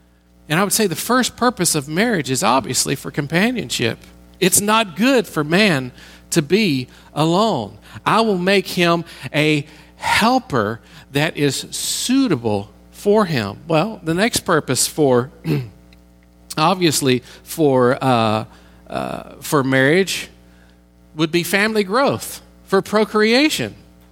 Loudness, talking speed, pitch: -18 LUFS, 120 wpm, 155 Hz